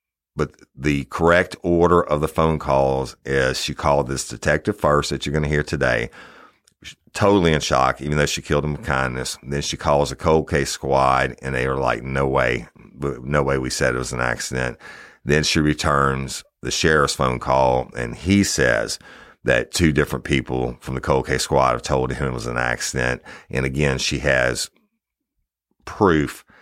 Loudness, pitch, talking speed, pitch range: -20 LUFS, 70 Hz, 190 wpm, 65-75 Hz